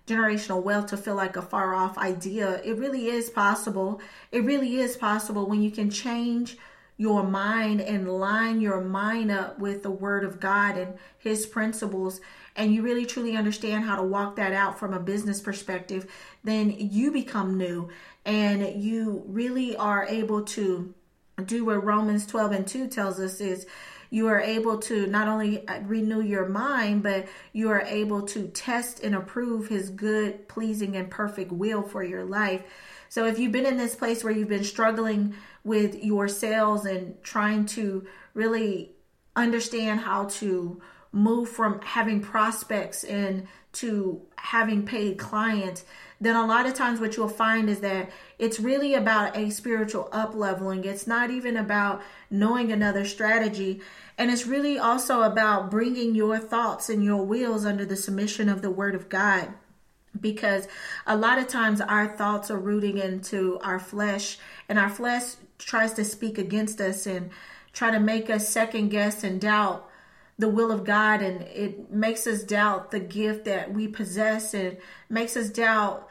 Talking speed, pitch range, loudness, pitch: 170 wpm, 195-225 Hz, -26 LUFS, 210 Hz